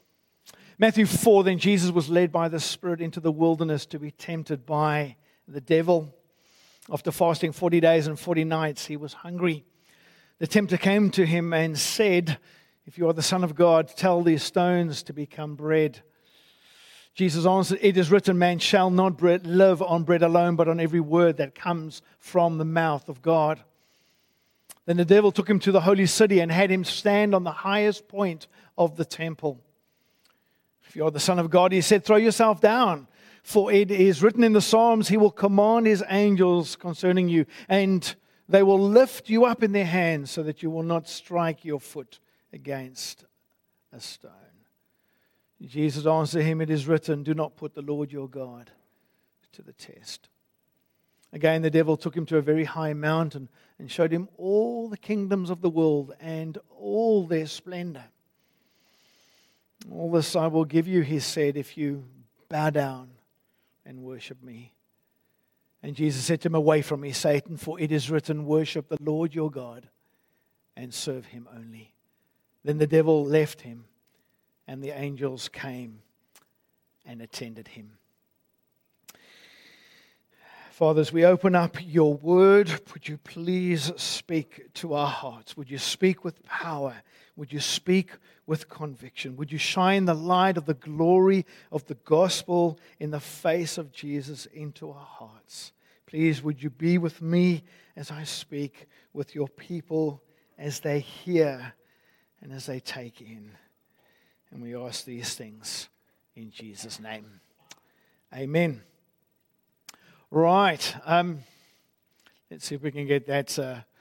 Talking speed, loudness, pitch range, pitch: 160 wpm, -24 LUFS, 145-180 Hz, 160 Hz